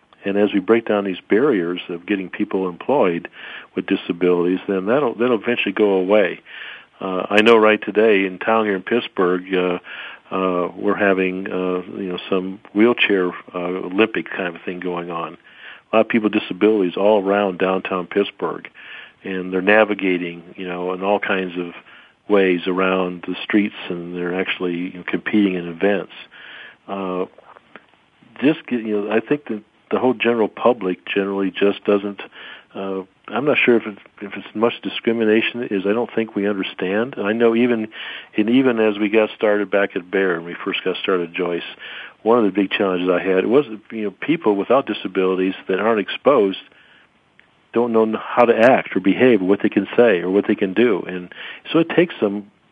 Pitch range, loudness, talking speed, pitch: 90-110 Hz, -19 LUFS, 190 wpm, 100 Hz